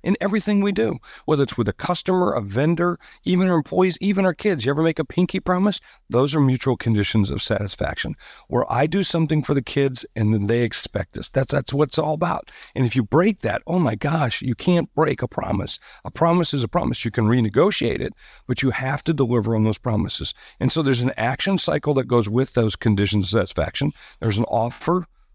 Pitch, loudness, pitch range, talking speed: 140 Hz, -21 LUFS, 115-175 Hz, 220 wpm